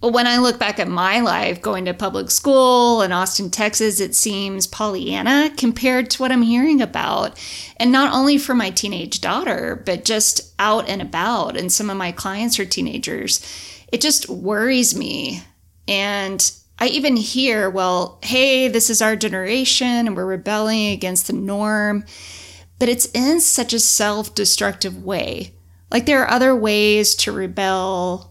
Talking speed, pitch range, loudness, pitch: 165 wpm, 190-245 Hz, -17 LUFS, 215 Hz